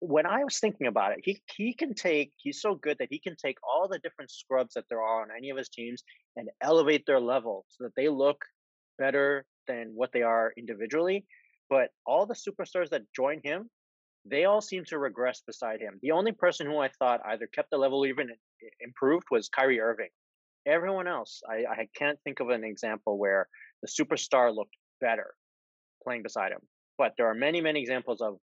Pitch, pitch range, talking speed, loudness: 140 Hz, 115-180 Hz, 205 wpm, -30 LUFS